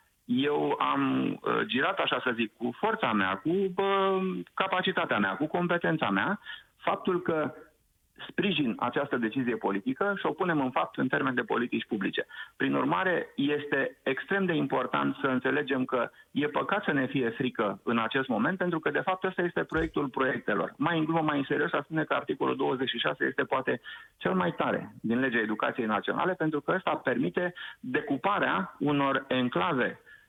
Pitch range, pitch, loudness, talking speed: 130-180 Hz, 145 Hz, -29 LUFS, 165 wpm